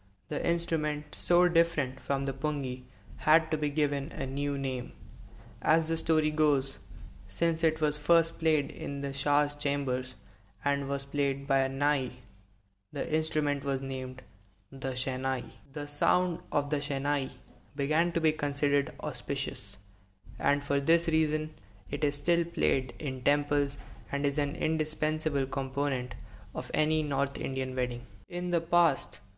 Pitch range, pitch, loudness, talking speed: 130-155 Hz, 145 Hz, -30 LUFS, 145 wpm